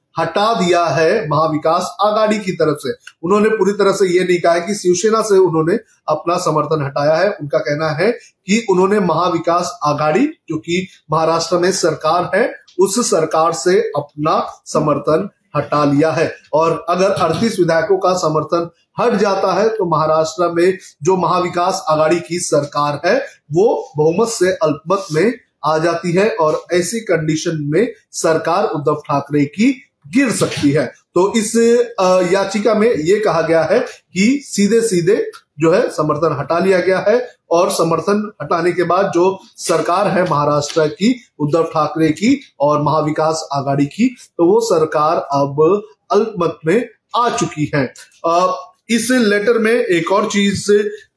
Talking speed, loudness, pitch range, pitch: 155 wpm, -15 LUFS, 155-205 Hz, 175 Hz